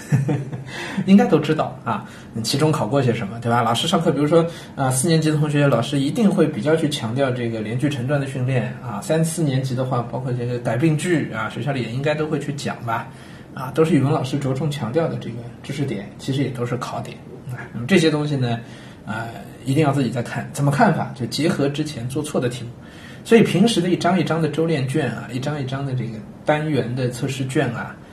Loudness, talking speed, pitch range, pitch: -21 LUFS, 335 characters per minute, 120-155 Hz, 140 Hz